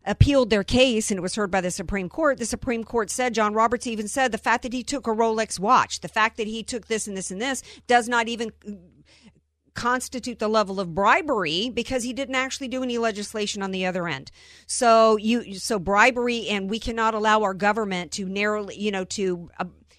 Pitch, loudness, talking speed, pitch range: 220 Hz, -23 LUFS, 215 wpm, 200-240 Hz